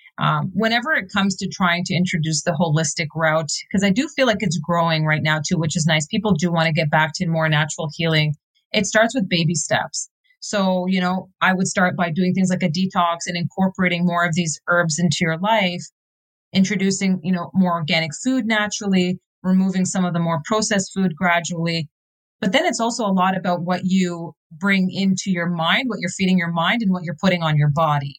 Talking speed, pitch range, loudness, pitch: 215 wpm, 165-190 Hz, -20 LUFS, 180 Hz